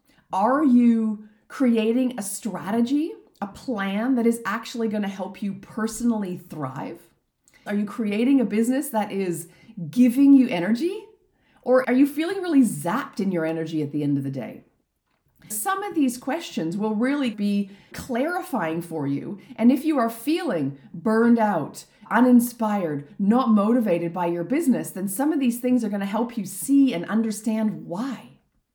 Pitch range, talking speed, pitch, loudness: 195-255 Hz, 165 wpm, 225 Hz, -23 LUFS